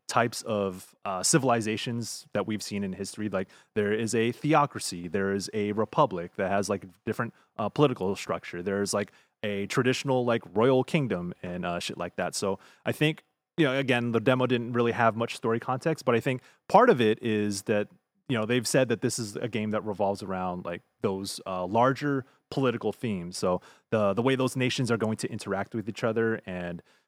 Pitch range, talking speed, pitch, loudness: 100-125 Hz, 200 wpm, 115 Hz, -28 LUFS